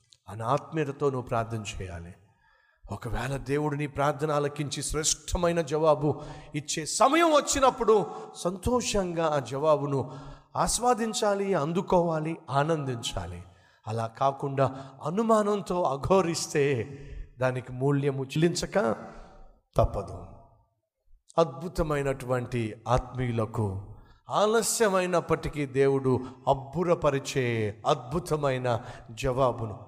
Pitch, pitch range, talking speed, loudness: 140 Hz, 125-165 Hz, 70 wpm, -28 LUFS